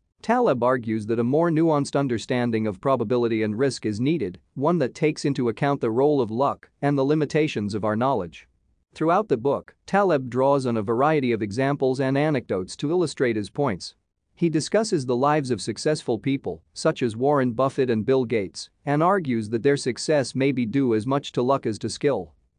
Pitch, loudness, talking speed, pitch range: 135 Hz, -23 LUFS, 195 wpm, 115-145 Hz